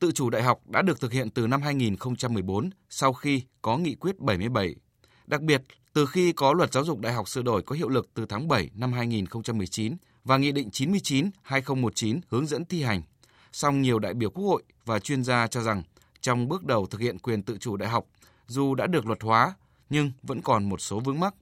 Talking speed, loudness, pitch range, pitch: 220 wpm, -27 LUFS, 110-140 Hz, 125 Hz